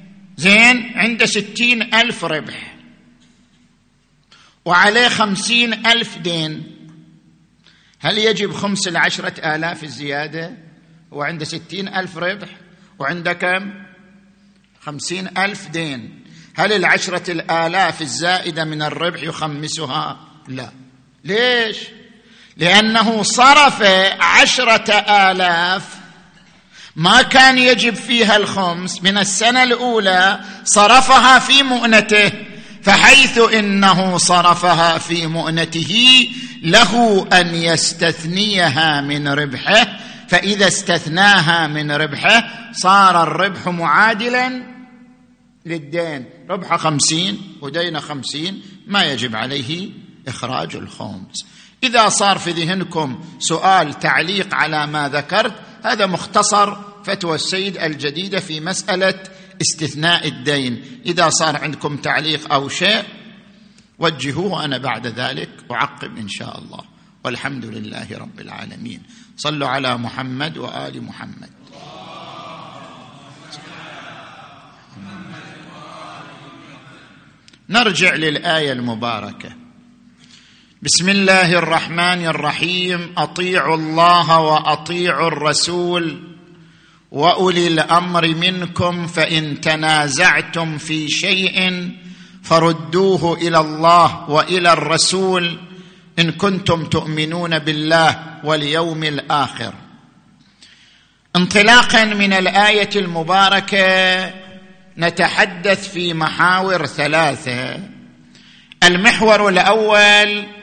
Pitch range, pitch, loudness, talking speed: 160-205 Hz, 180 Hz, -14 LUFS, 85 wpm